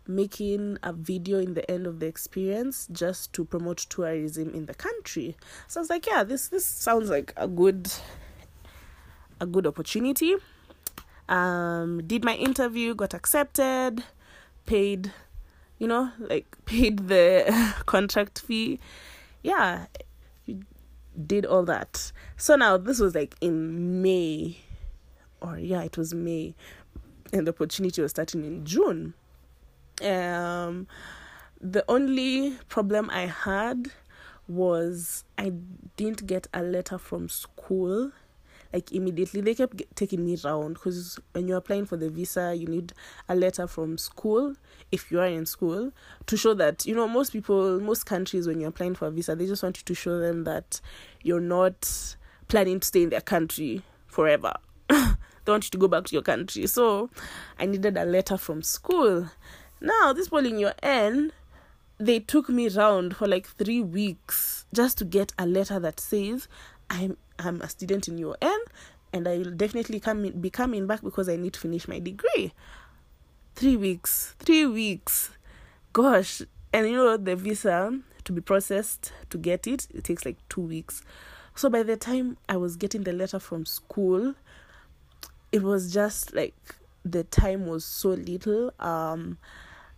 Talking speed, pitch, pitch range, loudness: 160 wpm, 185 Hz, 170-220 Hz, -27 LUFS